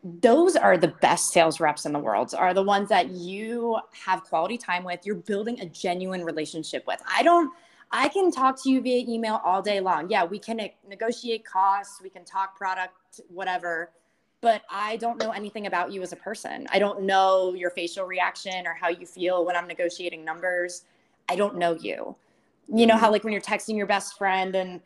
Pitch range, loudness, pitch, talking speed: 175-220 Hz, -25 LUFS, 190 Hz, 205 wpm